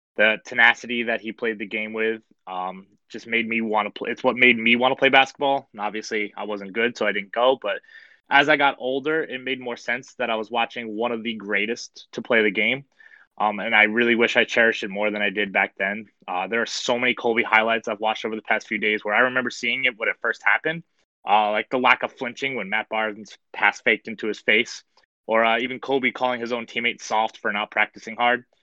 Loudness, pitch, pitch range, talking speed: -22 LUFS, 115 Hz, 110-125 Hz, 245 wpm